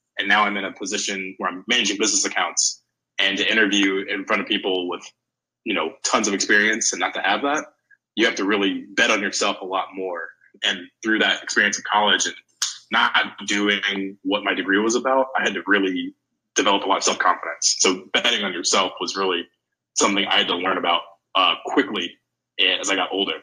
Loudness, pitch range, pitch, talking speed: -20 LUFS, 95-140 Hz, 100 Hz, 205 wpm